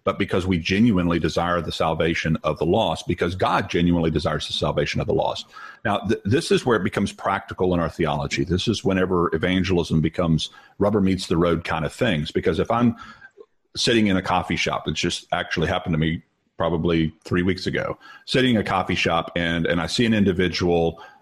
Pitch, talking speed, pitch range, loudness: 85 Hz, 200 wpm, 85-95 Hz, -22 LUFS